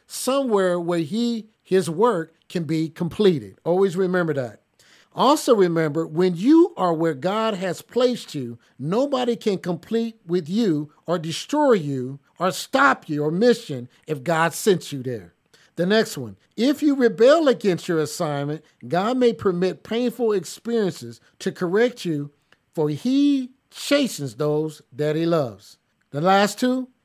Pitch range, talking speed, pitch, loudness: 155-230 Hz, 145 wpm, 180 Hz, -22 LUFS